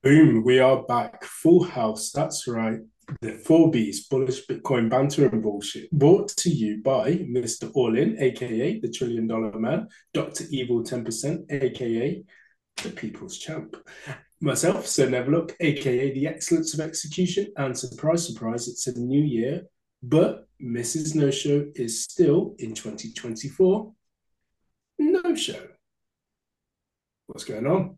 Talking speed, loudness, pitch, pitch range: 135 wpm, -24 LUFS, 130 Hz, 115-160 Hz